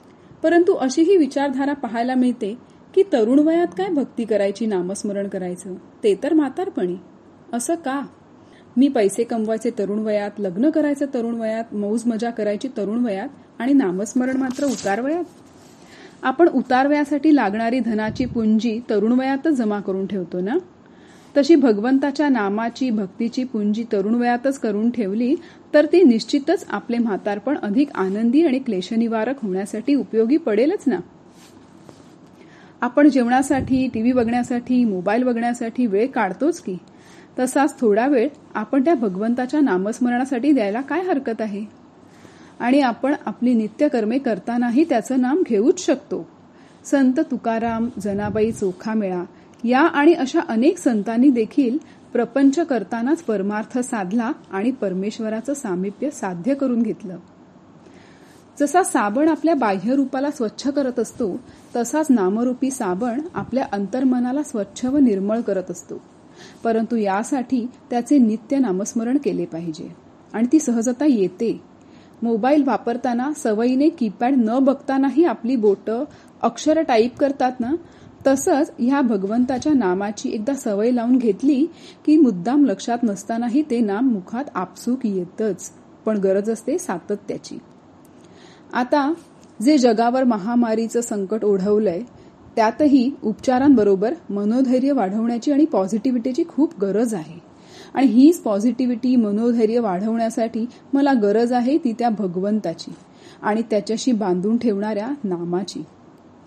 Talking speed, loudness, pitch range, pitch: 120 wpm, -20 LUFS, 215-280 Hz, 240 Hz